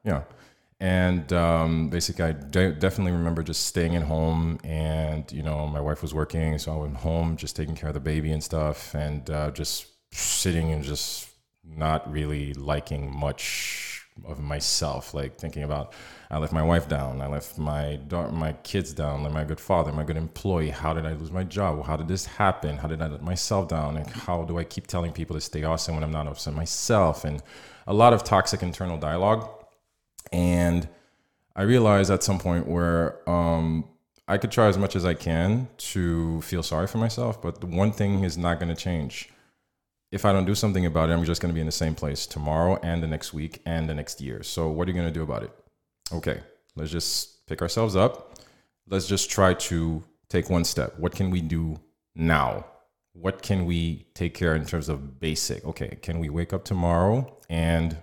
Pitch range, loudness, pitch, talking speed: 75-90 Hz, -26 LUFS, 80 Hz, 210 wpm